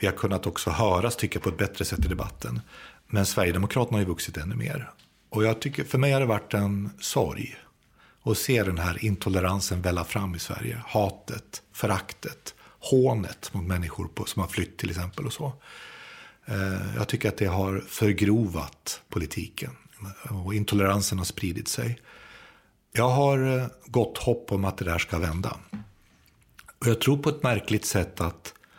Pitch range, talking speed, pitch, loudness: 95-115 Hz, 170 wpm, 100 Hz, -27 LUFS